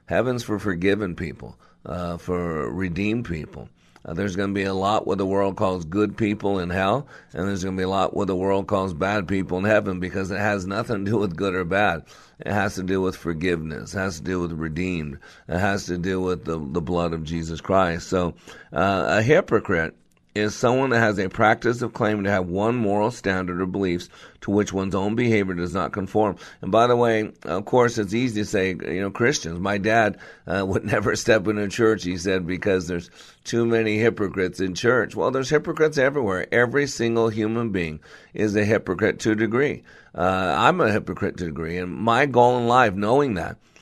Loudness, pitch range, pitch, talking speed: -23 LUFS, 90-110 Hz, 100 Hz, 215 wpm